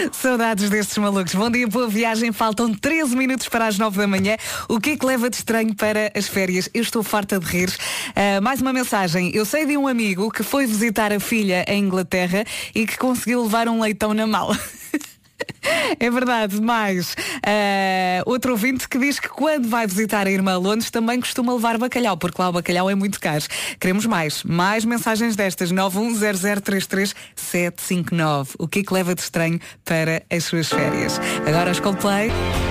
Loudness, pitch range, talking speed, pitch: -20 LUFS, 185-235 Hz, 185 wpm, 210 Hz